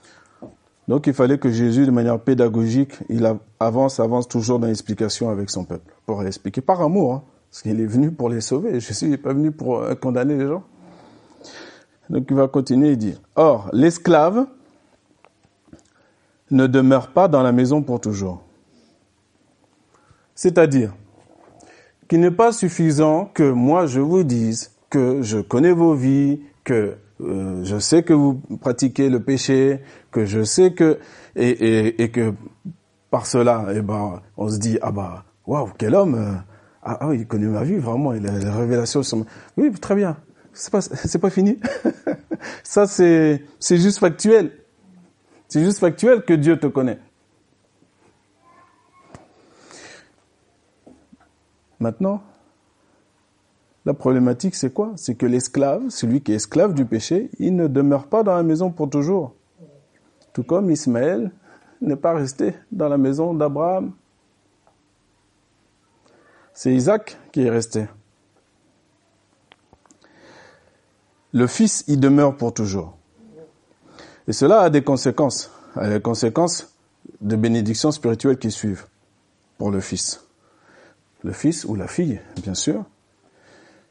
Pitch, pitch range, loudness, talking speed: 130 Hz, 110-160 Hz, -19 LUFS, 145 wpm